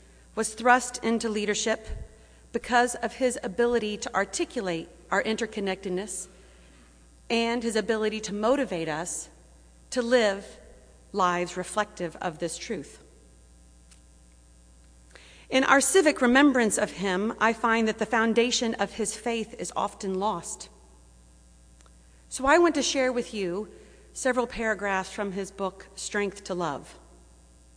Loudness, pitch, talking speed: -27 LUFS, 200 Hz, 125 wpm